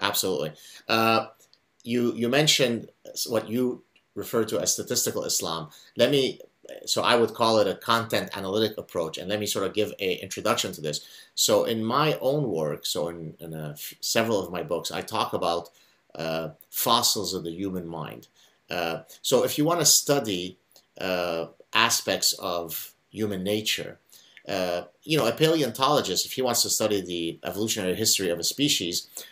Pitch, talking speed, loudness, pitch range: 105 Hz, 170 wpm, -25 LUFS, 85-120 Hz